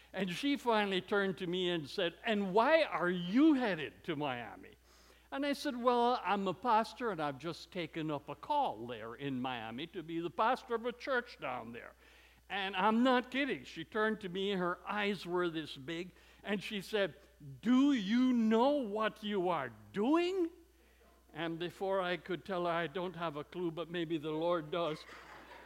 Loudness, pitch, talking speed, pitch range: -35 LUFS, 195 Hz, 185 wpm, 170-230 Hz